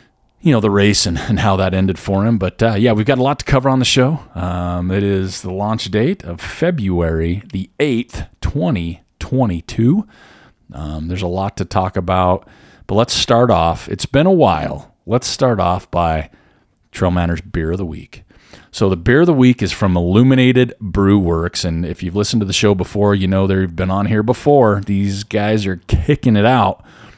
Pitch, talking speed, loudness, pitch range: 100 Hz, 200 wpm, -16 LUFS, 90-115 Hz